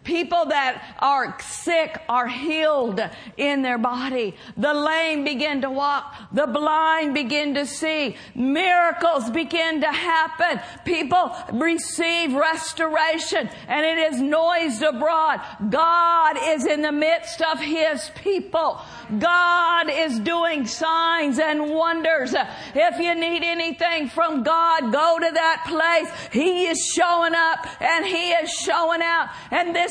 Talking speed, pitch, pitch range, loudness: 130 wpm, 320 Hz, 295-335 Hz, -21 LUFS